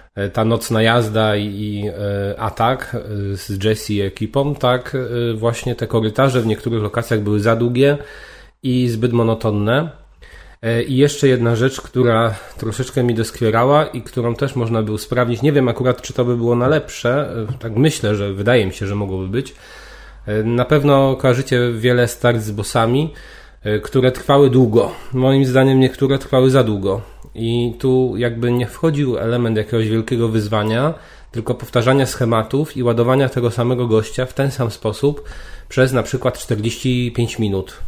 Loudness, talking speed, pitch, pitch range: -17 LUFS, 150 wpm, 120 Hz, 110-130 Hz